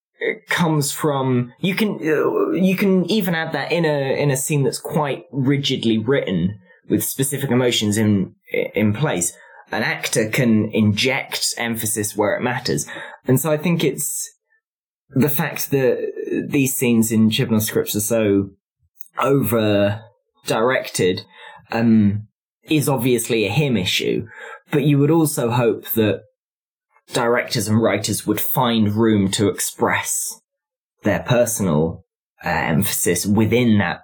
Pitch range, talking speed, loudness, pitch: 110-160 Hz, 135 wpm, -19 LUFS, 130 Hz